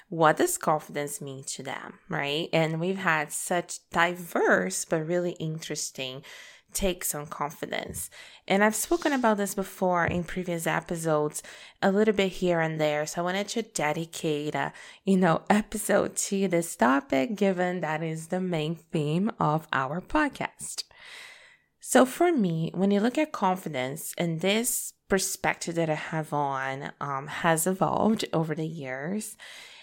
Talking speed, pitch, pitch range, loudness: 150 wpm, 175 Hz, 155-200 Hz, -27 LUFS